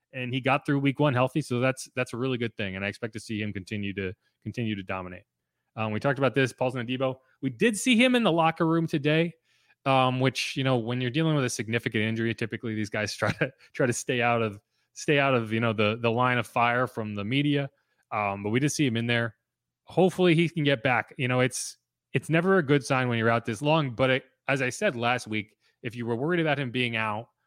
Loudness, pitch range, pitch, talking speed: -27 LUFS, 115-140 Hz, 125 Hz, 255 wpm